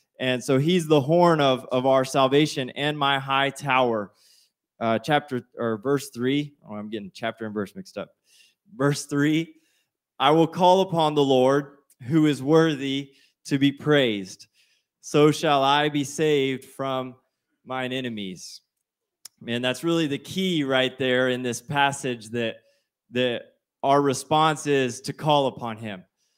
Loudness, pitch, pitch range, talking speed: -23 LUFS, 135 Hz, 125-150 Hz, 150 wpm